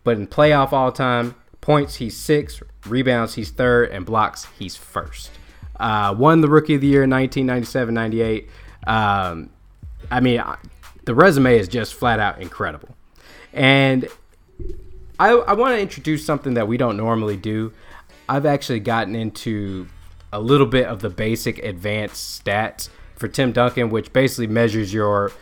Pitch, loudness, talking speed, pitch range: 115 Hz, -19 LUFS, 160 wpm, 105-130 Hz